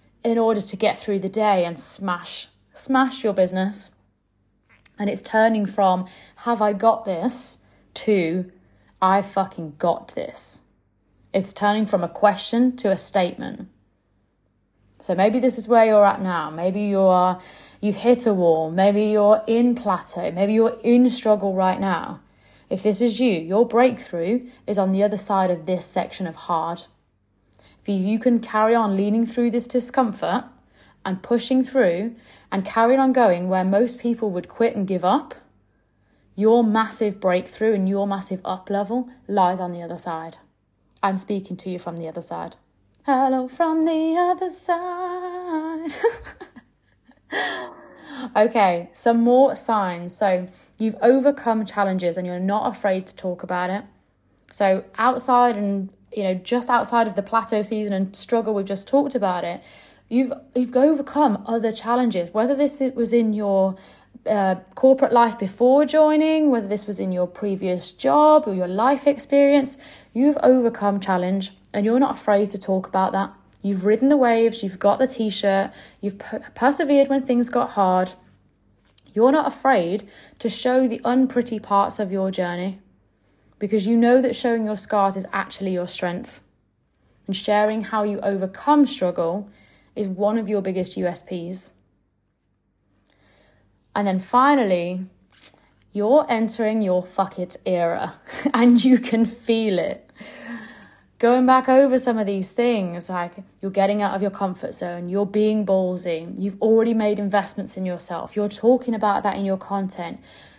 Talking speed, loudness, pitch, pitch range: 155 wpm, -21 LUFS, 205 Hz, 185-240 Hz